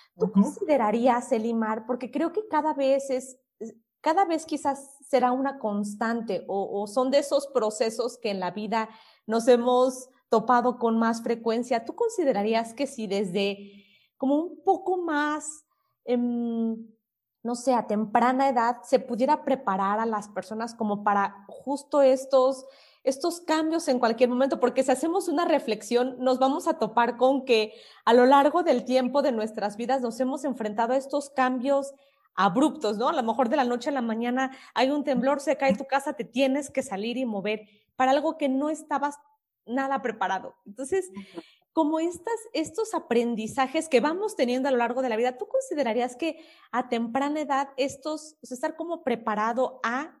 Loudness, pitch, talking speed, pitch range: -26 LUFS, 260 Hz, 170 wpm, 230-285 Hz